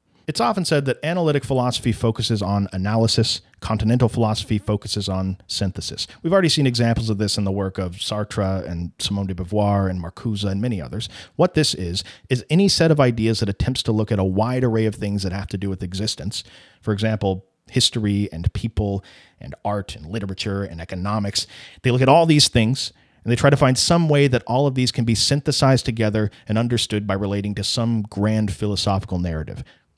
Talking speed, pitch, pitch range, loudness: 200 wpm, 110 Hz, 100-125 Hz, -21 LUFS